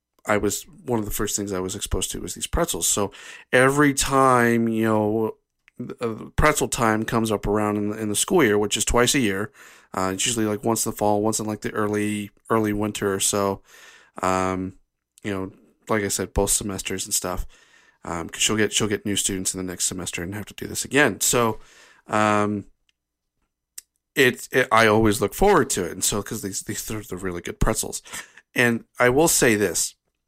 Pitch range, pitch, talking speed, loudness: 100-110 Hz, 105 Hz, 210 wpm, -22 LUFS